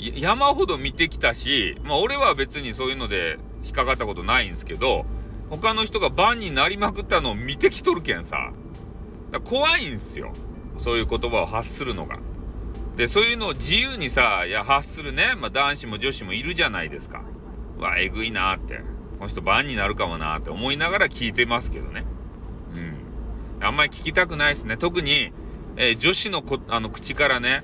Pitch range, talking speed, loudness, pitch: 105-170 Hz, 380 characters per minute, -22 LUFS, 130 Hz